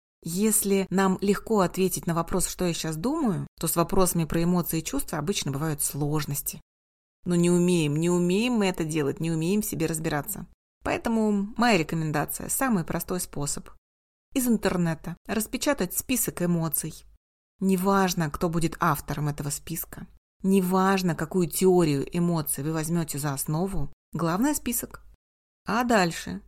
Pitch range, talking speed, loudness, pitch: 160-195 Hz, 140 wpm, -26 LUFS, 175 Hz